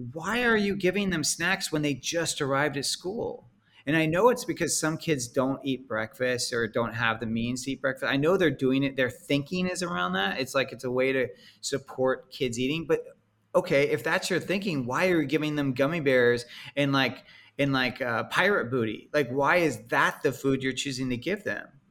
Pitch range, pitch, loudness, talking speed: 130-165 Hz, 140 Hz, -27 LUFS, 215 wpm